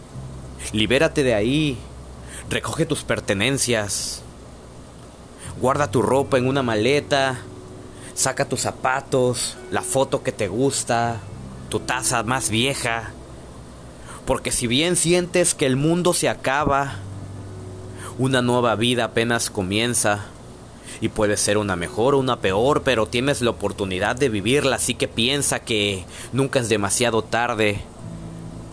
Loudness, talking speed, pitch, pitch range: -21 LUFS, 125 wpm, 115 Hz, 100-130 Hz